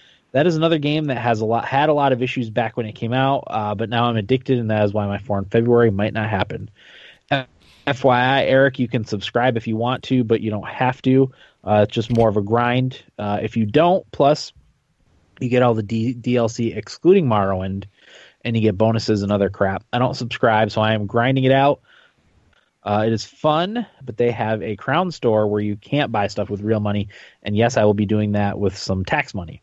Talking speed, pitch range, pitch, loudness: 230 wpm, 105-130 Hz, 115 Hz, -19 LUFS